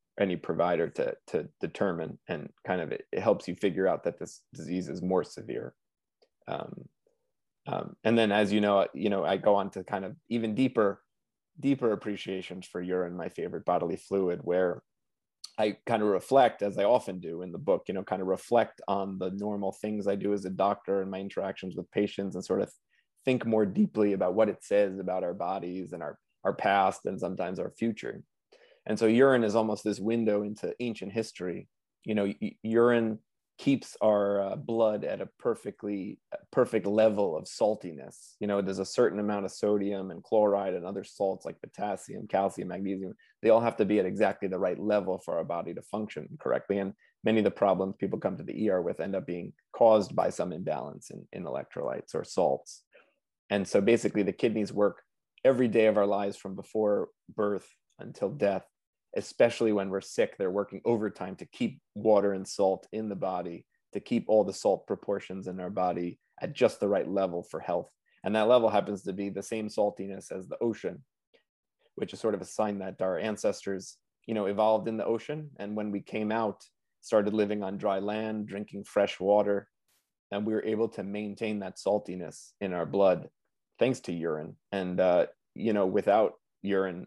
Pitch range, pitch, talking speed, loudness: 95-110 Hz, 100 Hz, 195 wpm, -30 LUFS